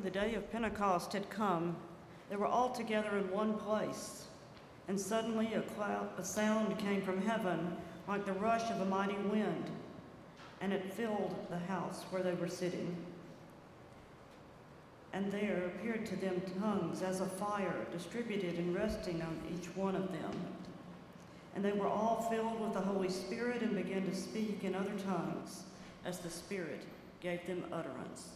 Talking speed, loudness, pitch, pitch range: 165 wpm, -38 LUFS, 195 Hz, 180-210 Hz